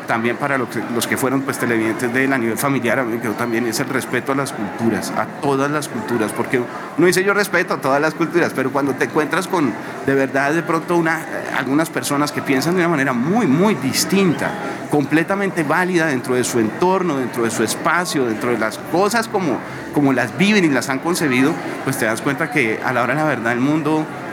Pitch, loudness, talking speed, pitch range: 140 Hz, -18 LUFS, 220 wpm, 125-160 Hz